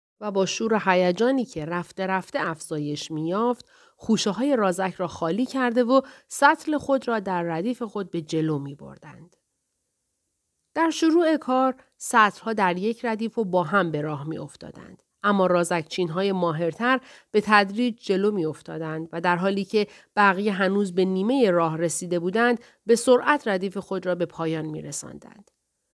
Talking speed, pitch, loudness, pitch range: 160 wpm, 195 Hz, -24 LUFS, 175-240 Hz